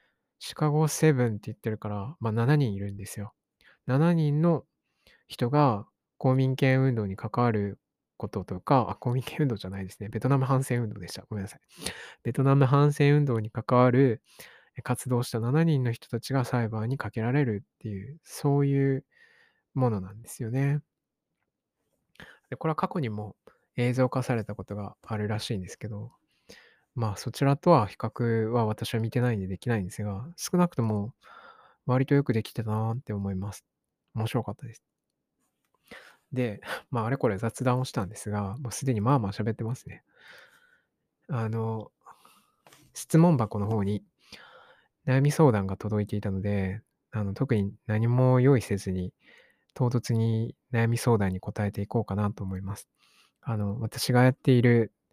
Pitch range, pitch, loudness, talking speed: 105-135 Hz, 115 Hz, -28 LUFS, 295 characters per minute